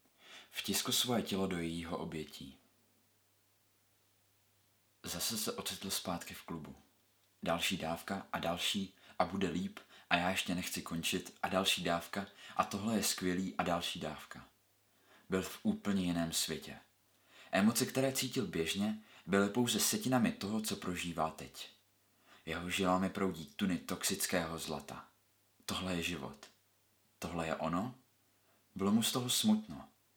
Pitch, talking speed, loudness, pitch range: 100 Hz, 135 wpm, -36 LUFS, 85-110 Hz